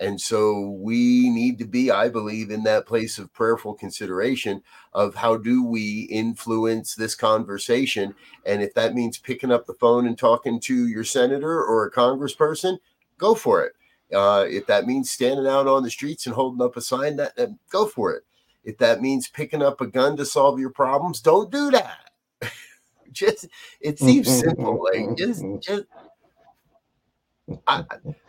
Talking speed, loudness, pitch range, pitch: 170 wpm, -22 LUFS, 115-160 Hz, 130 Hz